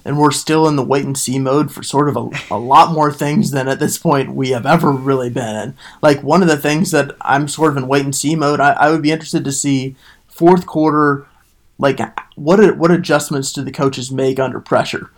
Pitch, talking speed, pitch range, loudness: 145 Hz, 240 wpm, 135-155 Hz, -15 LUFS